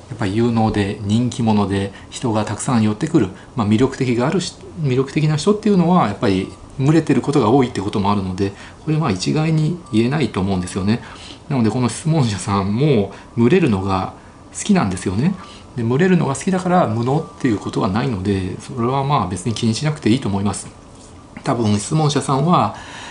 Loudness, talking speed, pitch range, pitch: -18 LUFS, 425 characters per minute, 100-140 Hz, 115 Hz